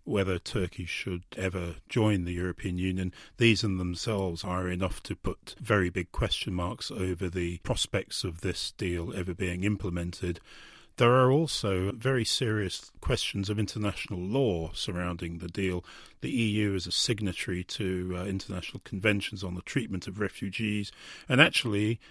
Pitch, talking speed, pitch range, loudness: 95 Hz, 150 wpm, 90-105 Hz, -30 LUFS